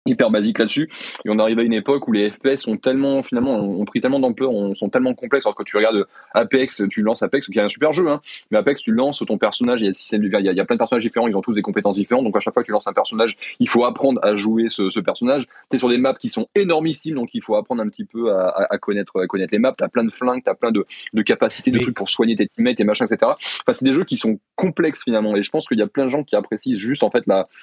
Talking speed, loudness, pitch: 310 wpm, -19 LUFS, 130 Hz